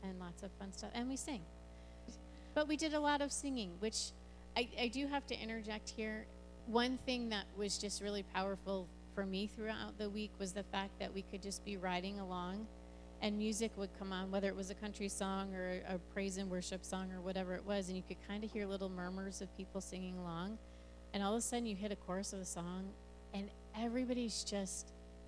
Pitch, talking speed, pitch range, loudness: 195 Hz, 220 wpm, 185-215 Hz, -42 LUFS